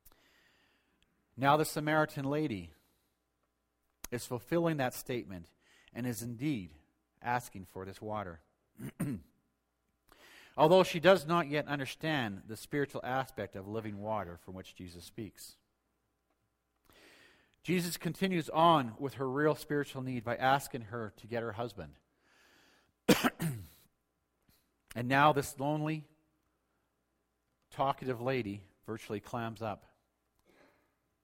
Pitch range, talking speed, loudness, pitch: 85-140 Hz, 105 wpm, -33 LUFS, 115 Hz